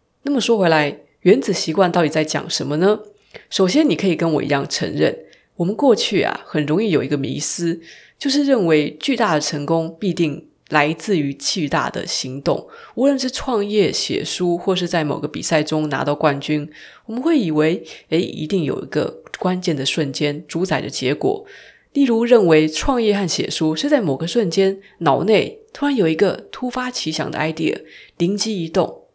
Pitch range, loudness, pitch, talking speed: 155-220 Hz, -19 LUFS, 175 Hz, 275 characters per minute